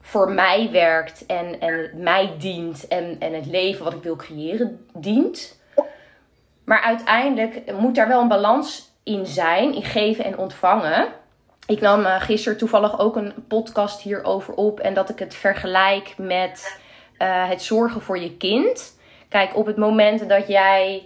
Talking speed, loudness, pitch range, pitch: 160 wpm, -20 LUFS, 185-220 Hz, 200 Hz